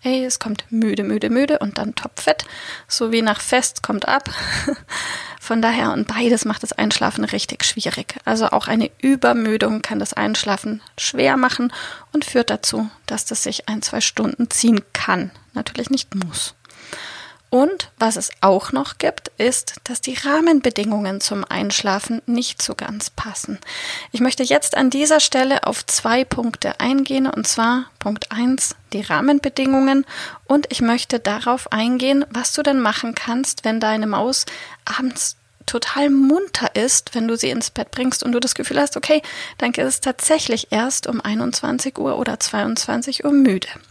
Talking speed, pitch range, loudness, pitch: 165 wpm, 225-275 Hz, -19 LUFS, 250 Hz